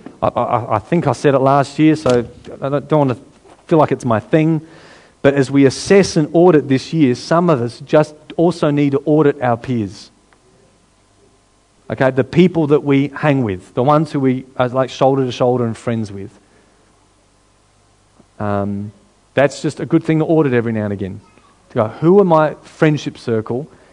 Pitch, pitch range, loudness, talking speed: 135 Hz, 110-150 Hz, -15 LUFS, 190 wpm